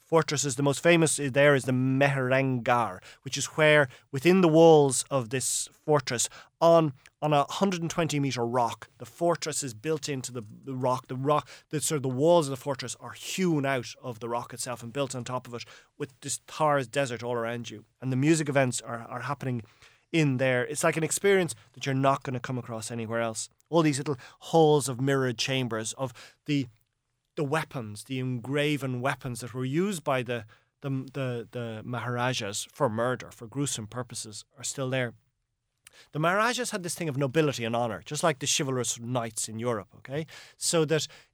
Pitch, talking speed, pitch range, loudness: 130 Hz, 195 wpm, 120-150 Hz, -27 LUFS